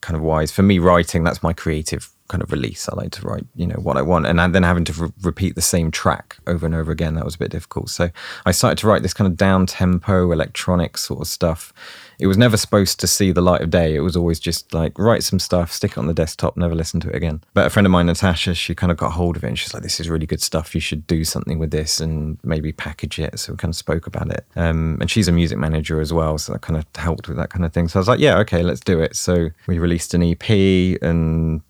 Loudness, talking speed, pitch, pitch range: -19 LUFS, 290 wpm, 85 Hz, 80-90 Hz